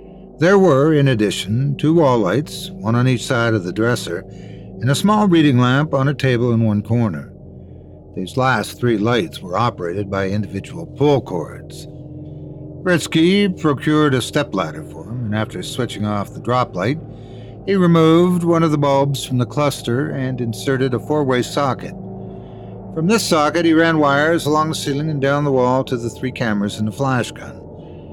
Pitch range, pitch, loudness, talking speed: 110-150 Hz, 130 Hz, -17 LUFS, 175 wpm